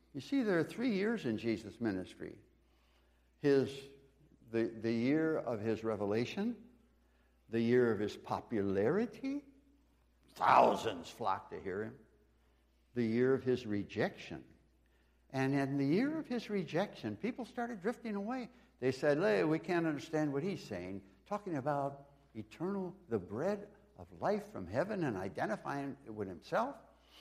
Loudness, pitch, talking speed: -36 LUFS, 135 Hz, 145 wpm